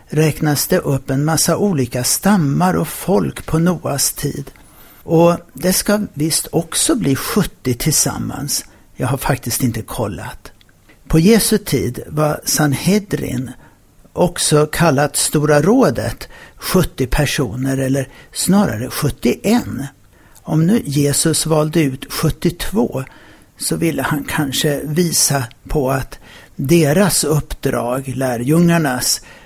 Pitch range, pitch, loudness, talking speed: 135-165 Hz, 150 Hz, -16 LUFS, 110 wpm